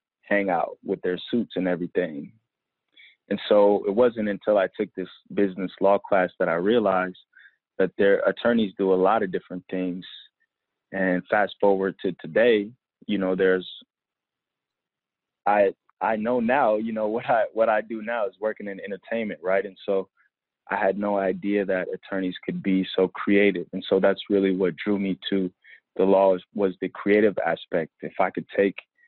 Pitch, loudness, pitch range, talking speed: 100 Hz, -24 LUFS, 95-105 Hz, 175 wpm